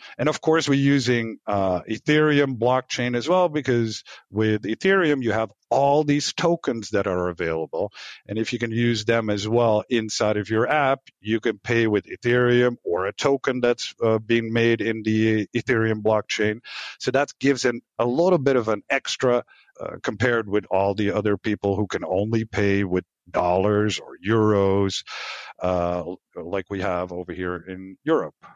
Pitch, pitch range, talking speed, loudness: 110 Hz, 105-125 Hz, 170 wpm, -23 LUFS